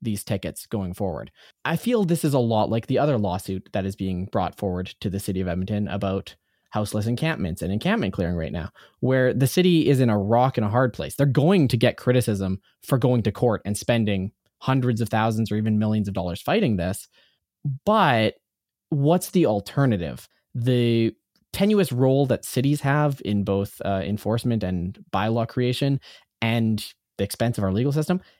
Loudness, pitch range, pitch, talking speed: -23 LUFS, 100-130 Hz, 115 Hz, 185 wpm